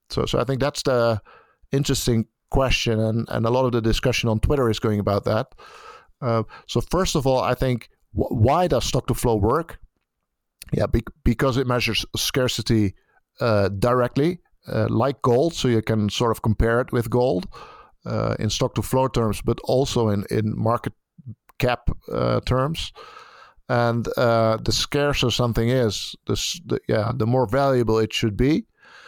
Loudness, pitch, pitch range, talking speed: -22 LUFS, 120 Hz, 110-130 Hz, 175 wpm